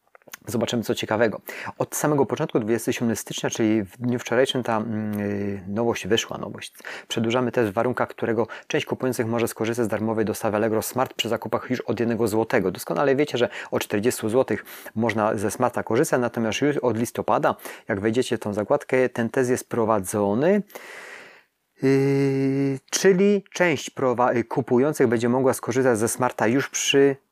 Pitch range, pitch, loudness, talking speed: 110-135 Hz, 120 Hz, -23 LUFS, 160 wpm